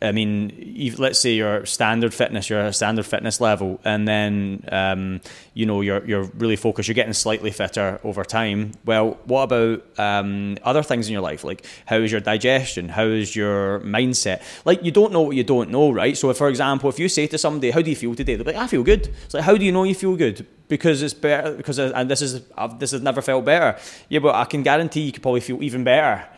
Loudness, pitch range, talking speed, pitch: -20 LUFS, 105-140 Hz, 240 wpm, 120 Hz